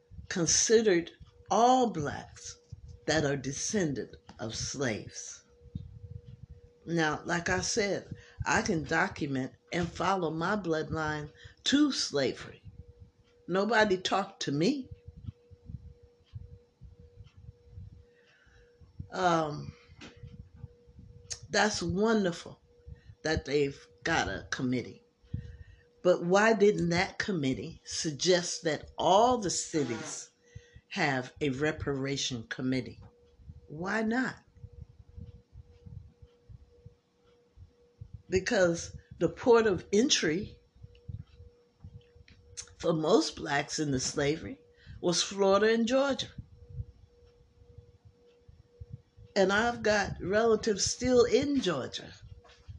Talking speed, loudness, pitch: 80 wpm, -29 LUFS, 135 Hz